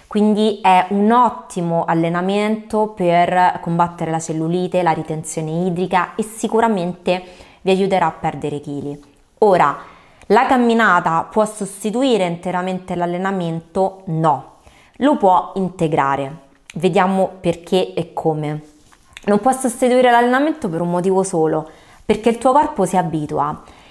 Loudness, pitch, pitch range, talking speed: -17 LUFS, 180 Hz, 165-215 Hz, 120 wpm